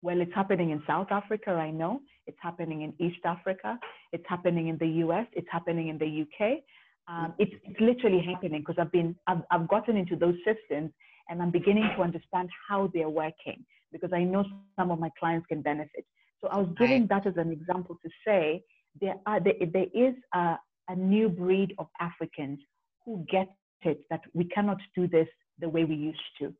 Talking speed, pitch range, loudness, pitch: 200 wpm, 165-200 Hz, -30 LUFS, 175 Hz